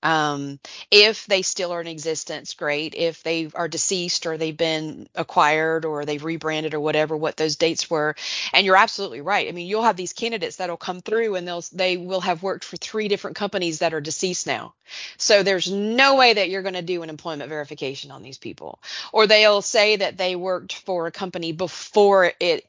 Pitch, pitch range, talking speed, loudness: 180 Hz, 160-195 Hz, 210 wpm, -21 LUFS